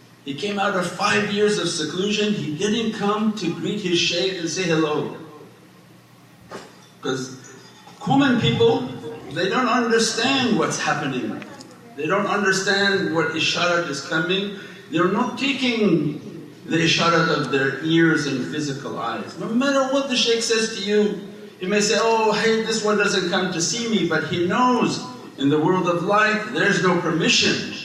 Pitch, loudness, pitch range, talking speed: 190 Hz, -20 LUFS, 165-215 Hz, 160 wpm